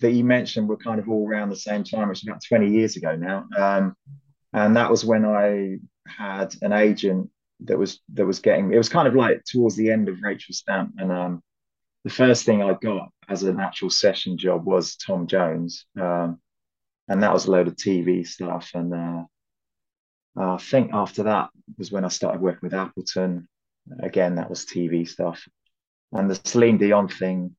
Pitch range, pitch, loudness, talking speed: 90-110 Hz, 95 Hz, -22 LUFS, 195 wpm